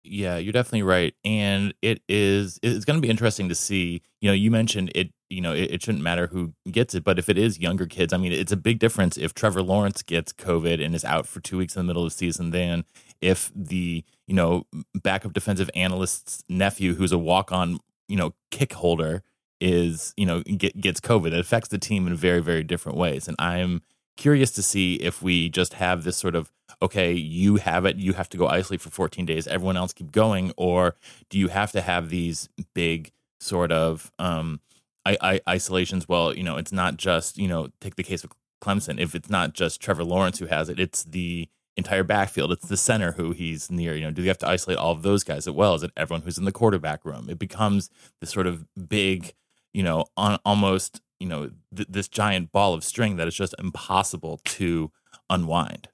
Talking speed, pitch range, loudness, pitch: 225 wpm, 85-100 Hz, -24 LUFS, 90 Hz